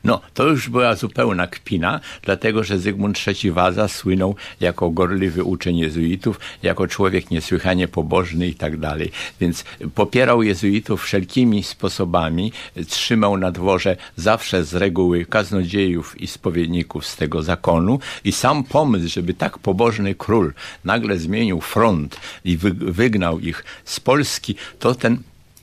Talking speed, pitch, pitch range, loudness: 135 wpm, 95 Hz, 85-105 Hz, -19 LUFS